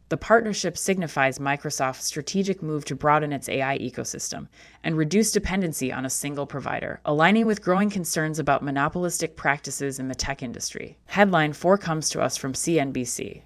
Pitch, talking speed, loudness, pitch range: 150 Hz, 160 wpm, -24 LUFS, 135-175 Hz